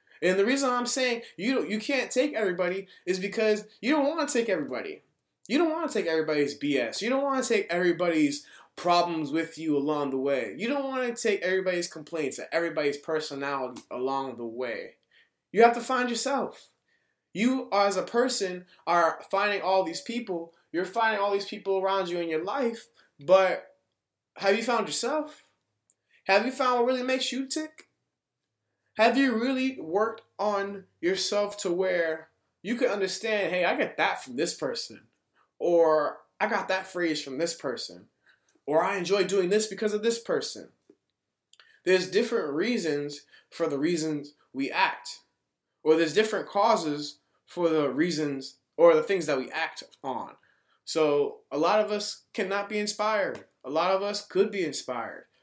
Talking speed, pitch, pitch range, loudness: 170 wpm, 200 Hz, 165-240 Hz, -27 LUFS